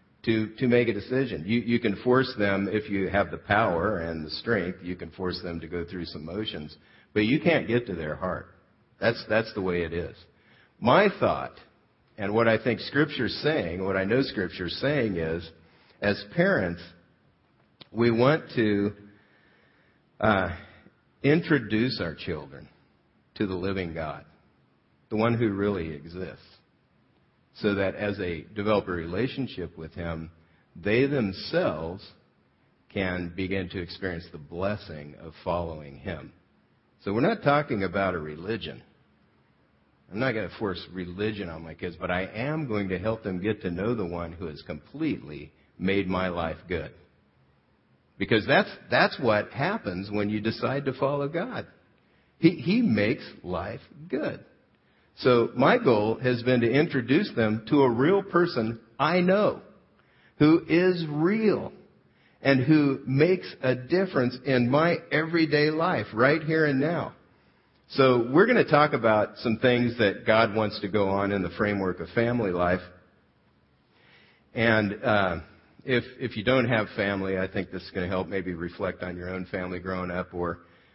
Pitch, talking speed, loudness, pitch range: 100 Hz, 160 wpm, -26 LUFS, 90-120 Hz